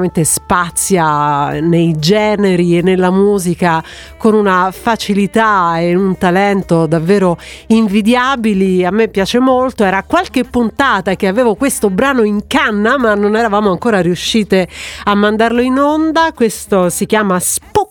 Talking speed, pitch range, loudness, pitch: 135 wpm, 180-230 Hz, -12 LUFS, 205 Hz